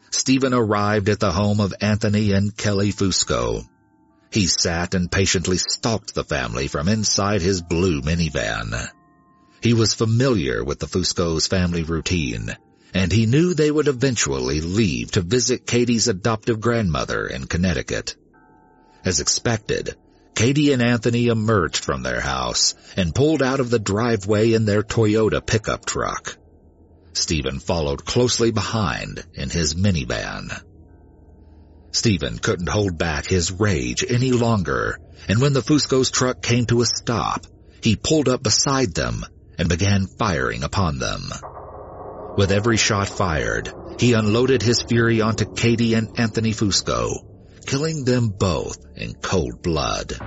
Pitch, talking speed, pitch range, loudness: 105 Hz, 140 wpm, 90-120 Hz, -20 LUFS